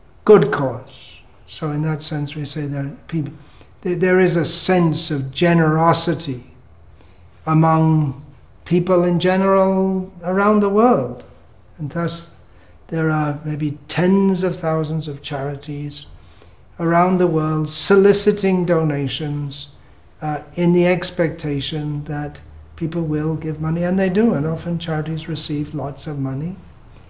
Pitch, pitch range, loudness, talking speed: 155 Hz, 145-175 Hz, -18 LUFS, 125 wpm